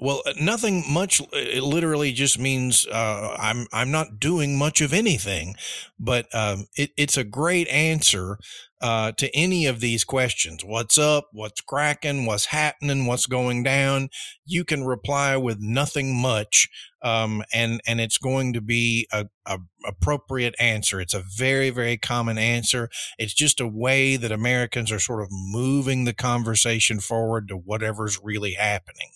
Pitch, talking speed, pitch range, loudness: 120 Hz, 160 wpm, 110-140 Hz, -22 LUFS